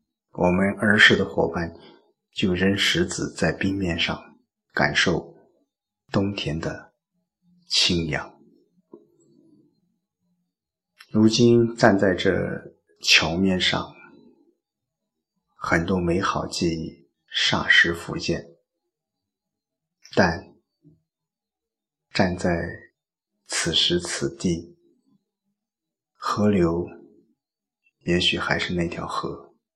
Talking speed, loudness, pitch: 115 characters per minute, -22 LUFS, 105 Hz